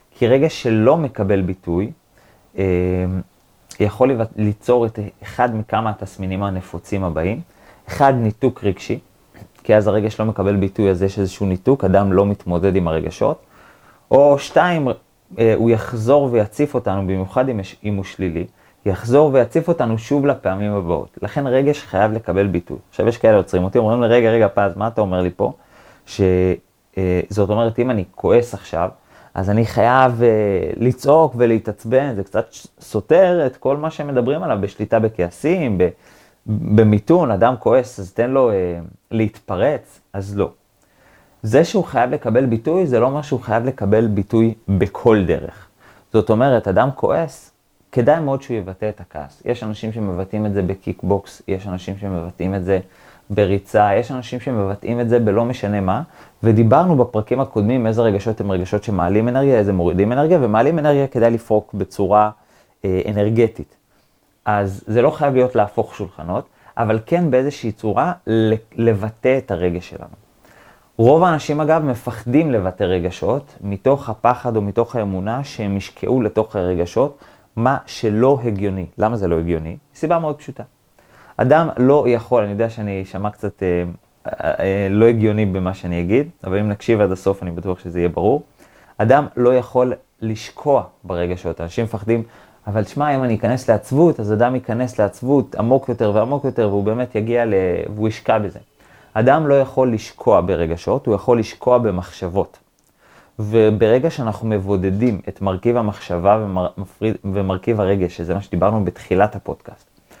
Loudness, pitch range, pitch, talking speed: -18 LUFS, 95-120 Hz, 105 Hz, 155 wpm